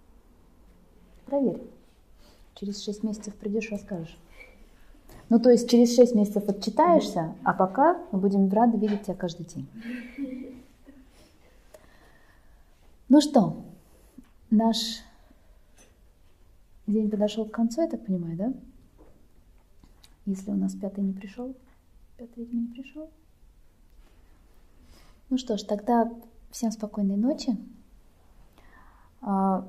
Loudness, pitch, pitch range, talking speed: -26 LUFS, 210 Hz, 175-240 Hz, 100 wpm